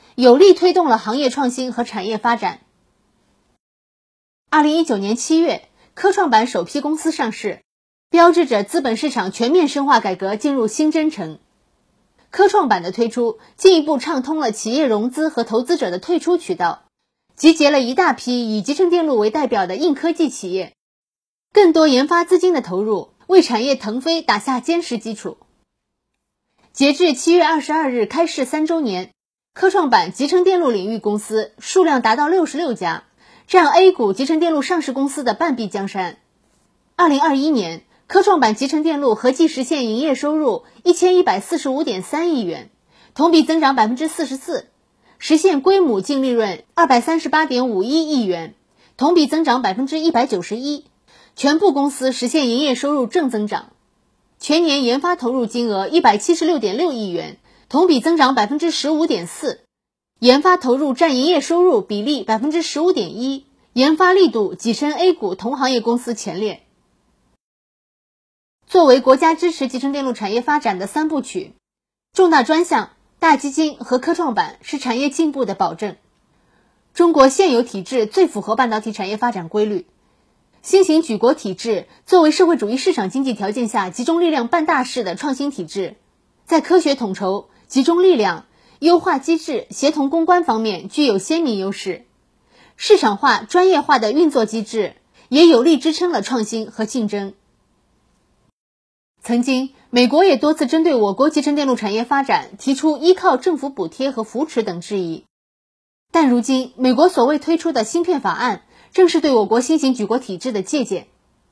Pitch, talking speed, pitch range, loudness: 280 Hz, 270 characters per minute, 230-330 Hz, -17 LUFS